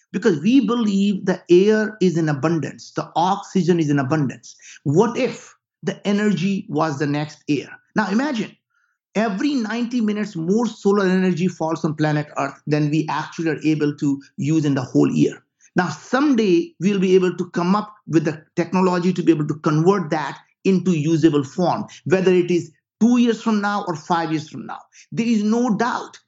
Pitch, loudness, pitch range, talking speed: 180 Hz, -20 LUFS, 160-210 Hz, 185 wpm